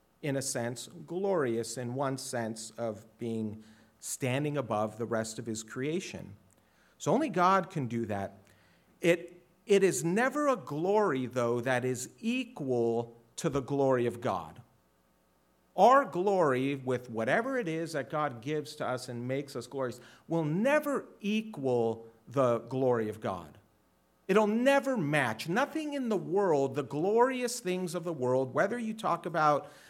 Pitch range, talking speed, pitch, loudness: 115-180 Hz, 155 wpm, 135 Hz, -31 LUFS